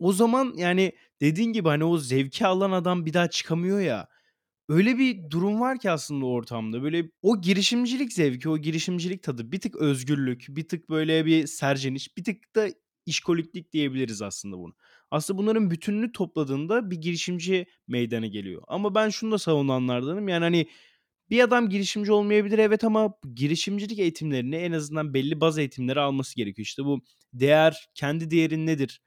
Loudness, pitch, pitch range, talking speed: -25 LUFS, 165 Hz, 140-195 Hz, 165 wpm